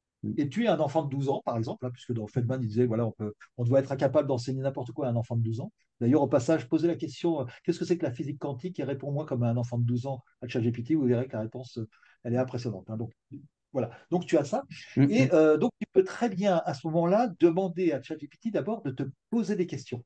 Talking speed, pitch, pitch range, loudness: 270 wpm, 140 Hz, 120-165 Hz, -29 LUFS